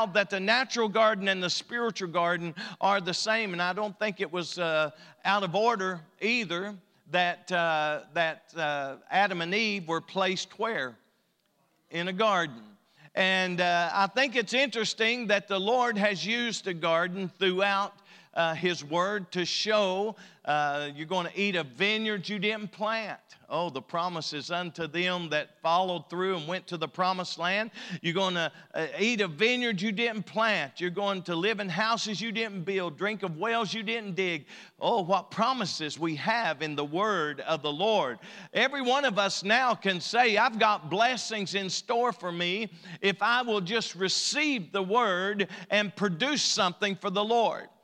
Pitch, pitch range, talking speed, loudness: 195 Hz, 175-220 Hz, 175 wpm, -28 LUFS